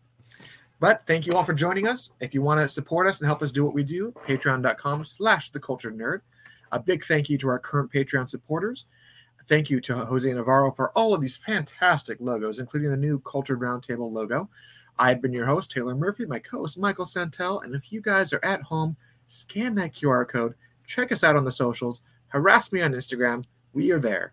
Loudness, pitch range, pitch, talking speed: -25 LUFS, 125-175 Hz, 140 Hz, 200 wpm